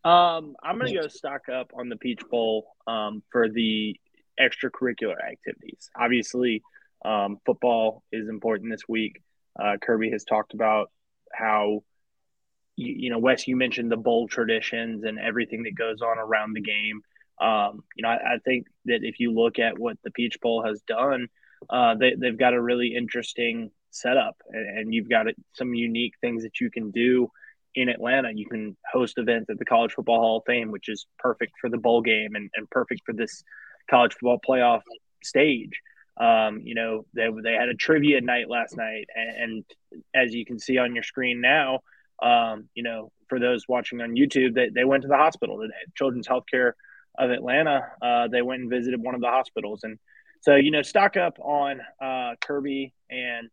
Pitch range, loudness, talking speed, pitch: 110-125 Hz, -25 LUFS, 190 wpm, 120 Hz